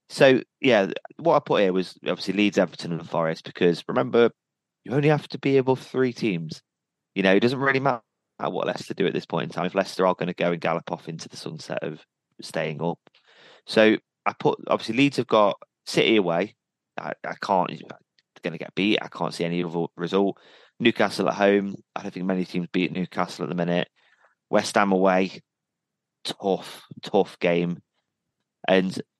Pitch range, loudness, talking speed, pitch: 85-110 Hz, -24 LUFS, 195 wpm, 95 Hz